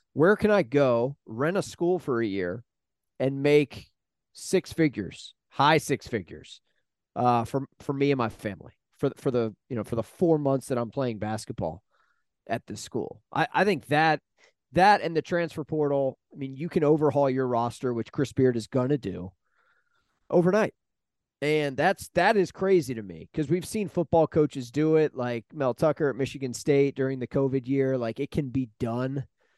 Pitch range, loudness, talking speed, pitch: 120-155 Hz, -26 LUFS, 185 wpm, 135 Hz